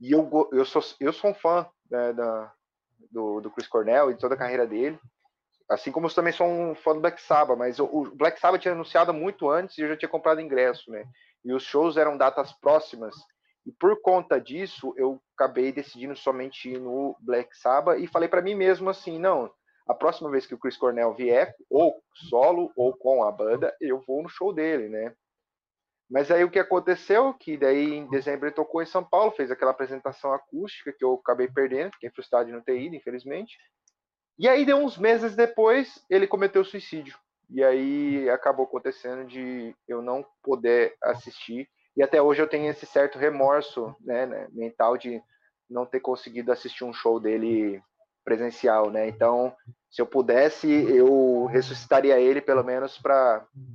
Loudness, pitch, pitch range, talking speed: -24 LUFS, 140 Hz, 125-170 Hz, 190 wpm